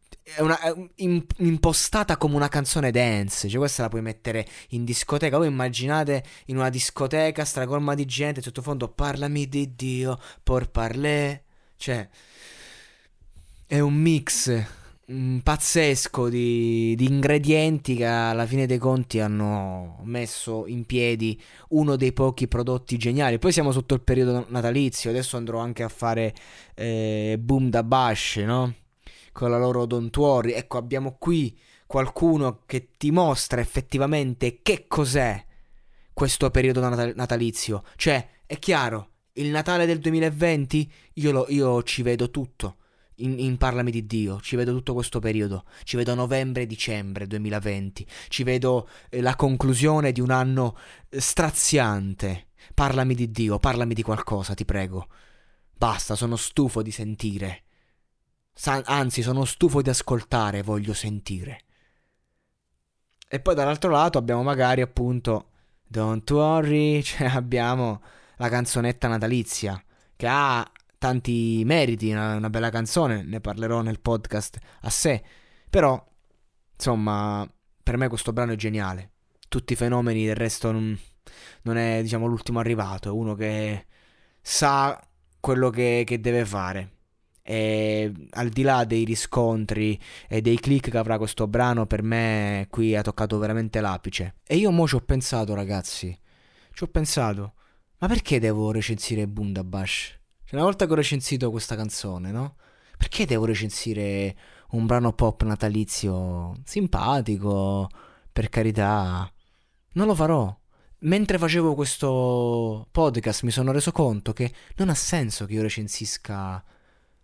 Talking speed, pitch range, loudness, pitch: 140 wpm, 110-135 Hz, -24 LUFS, 120 Hz